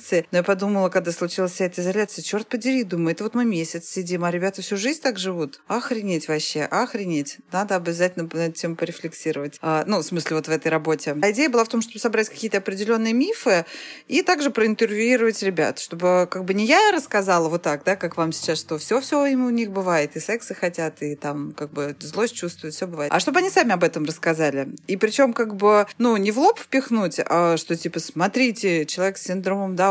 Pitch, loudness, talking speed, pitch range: 185 Hz, -22 LUFS, 210 wpm, 165-225 Hz